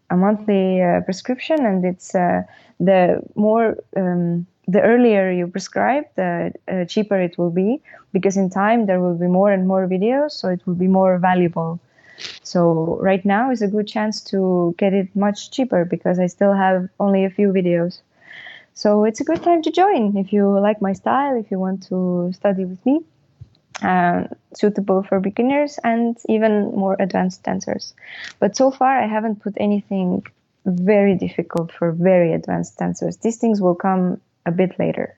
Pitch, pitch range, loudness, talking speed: 195 Hz, 180-215 Hz, -19 LUFS, 175 wpm